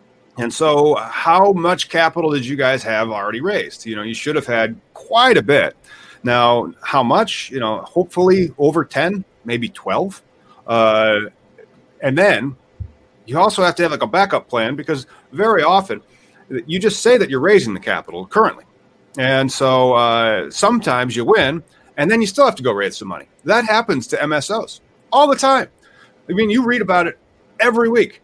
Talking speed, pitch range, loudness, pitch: 180 wpm, 120-180 Hz, -16 LUFS, 145 Hz